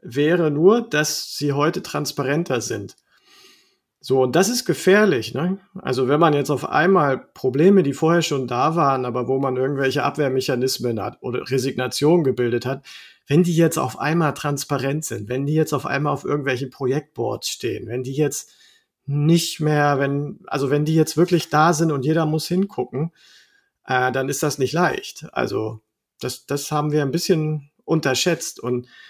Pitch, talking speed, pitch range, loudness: 150 Hz, 170 wpm, 135-170 Hz, -21 LUFS